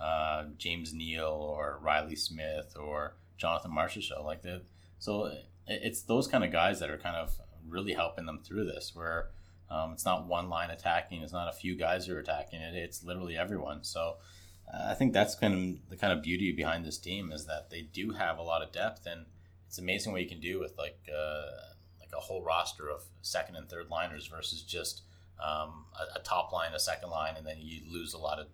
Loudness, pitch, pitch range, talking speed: -35 LUFS, 85 Hz, 80-90 Hz, 220 wpm